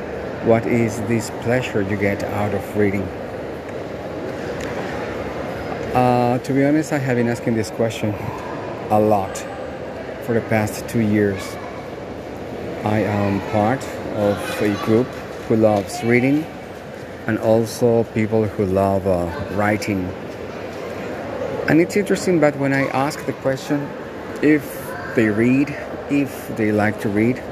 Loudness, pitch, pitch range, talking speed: -21 LUFS, 110 Hz, 105-125 Hz, 130 wpm